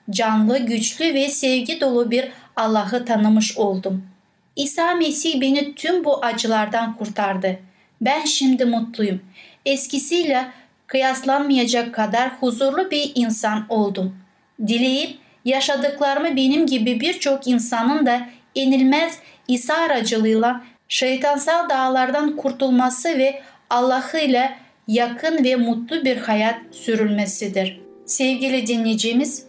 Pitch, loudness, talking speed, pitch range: 255 Hz, -19 LUFS, 100 wpm, 225-275 Hz